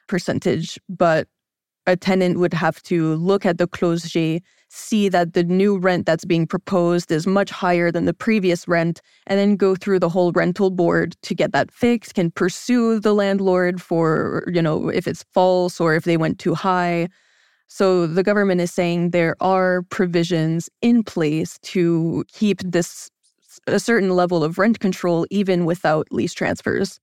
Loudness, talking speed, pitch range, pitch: -19 LUFS, 170 wpm, 170-195 Hz, 180 Hz